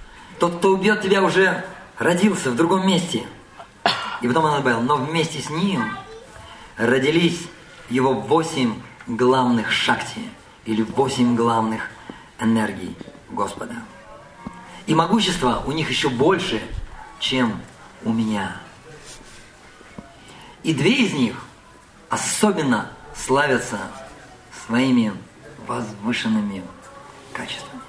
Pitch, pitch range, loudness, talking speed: 150 Hz, 120-185 Hz, -21 LUFS, 95 wpm